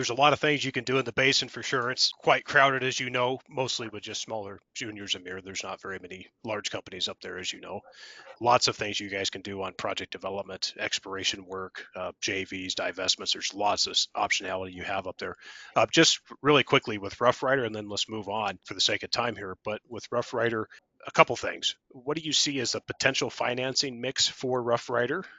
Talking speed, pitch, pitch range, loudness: 225 wpm, 115 Hz, 95-130 Hz, -27 LUFS